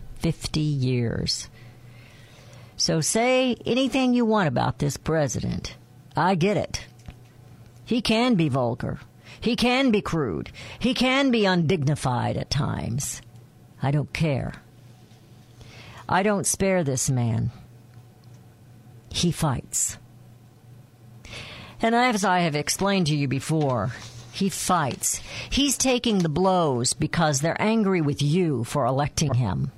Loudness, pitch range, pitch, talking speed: -24 LUFS, 120-185 Hz, 140 Hz, 120 wpm